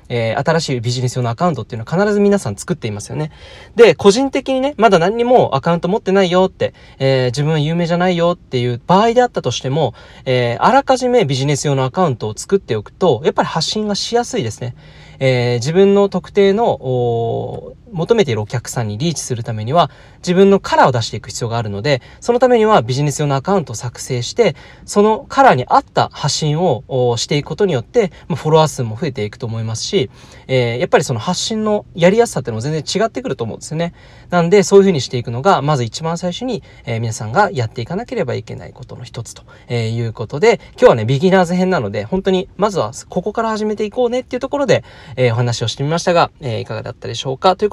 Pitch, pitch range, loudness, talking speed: 150 Hz, 125-195 Hz, -16 LUFS, 470 characters per minute